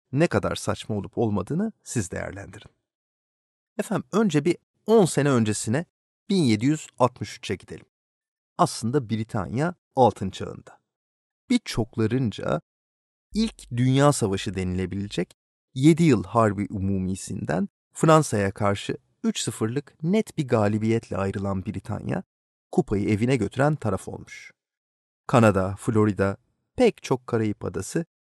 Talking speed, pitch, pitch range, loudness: 100 wpm, 110 Hz, 100-145 Hz, -25 LUFS